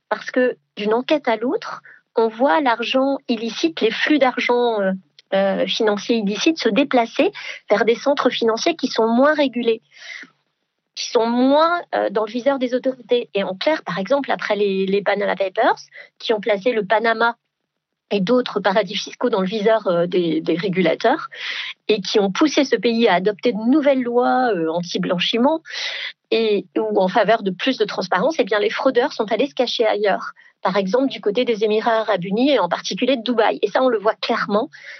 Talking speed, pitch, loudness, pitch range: 185 wpm, 230 Hz, -19 LUFS, 210-260 Hz